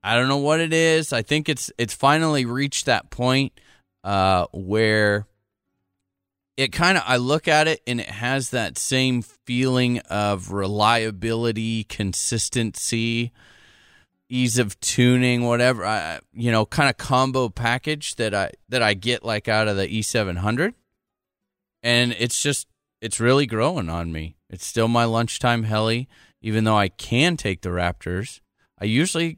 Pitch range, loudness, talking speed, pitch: 100-130 Hz, -21 LUFS, 155 wpm, 115 Hz